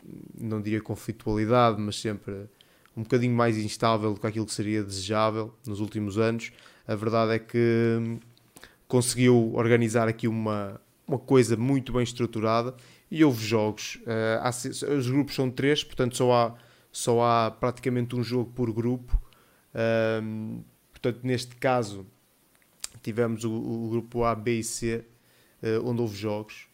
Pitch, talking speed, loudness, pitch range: 115 Hz, 135 wpm, -27 LUFS, 110-125 Hz